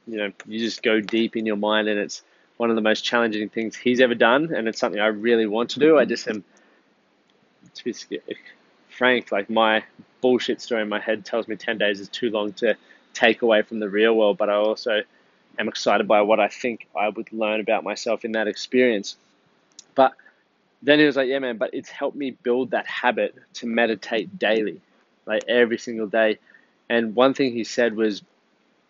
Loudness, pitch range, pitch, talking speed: -22 LUFS, 105-120 Hz, 115 Hz, 205 wpm